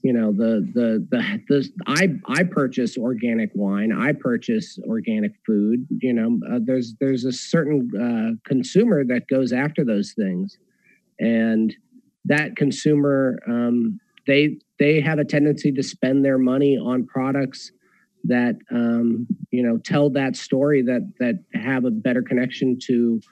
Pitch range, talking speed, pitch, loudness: 125-190 Hz, 150 wpm, 135 Hz, -21 LUFS